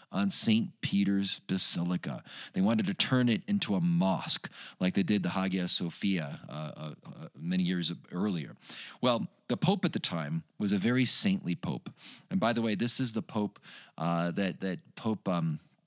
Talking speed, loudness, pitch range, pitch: 180 wpm, -30 LUFS, 90-145 Hz, 100 Hz